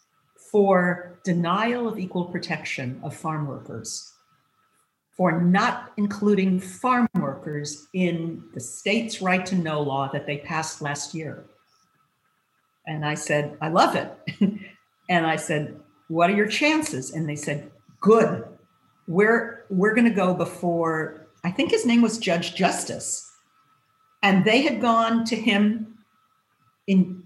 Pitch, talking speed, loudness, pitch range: 180 Hz, 135 wpm, -23 LUFS, 160-220 Hz